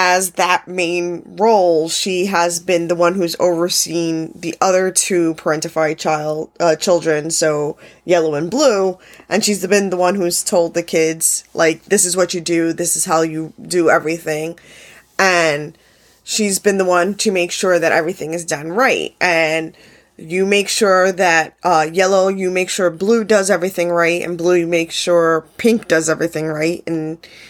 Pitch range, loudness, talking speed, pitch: 160-185 Hz, -16 LUFS, 175 wpm, 175 Hz